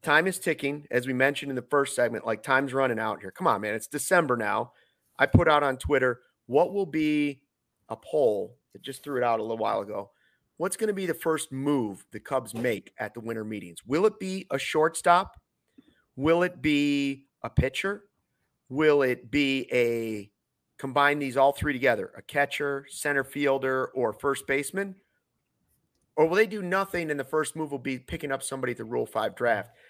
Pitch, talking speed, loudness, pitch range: 140 Hz, 200 wpm, -27 LUFS, 125-155 Hz